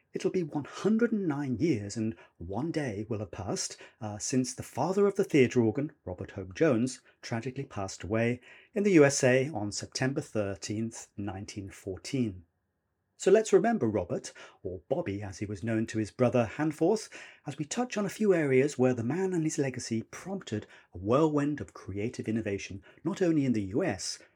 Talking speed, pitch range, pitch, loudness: 170 wpm, 105-155 Hz, 125 Hz, -30 LUFS